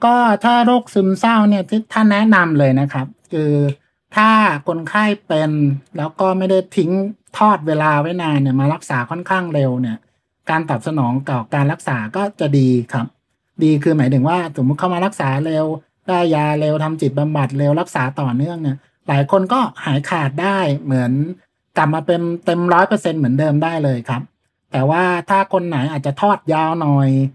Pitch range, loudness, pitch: 140-185 Hz, -17 LUFS, 155 Hz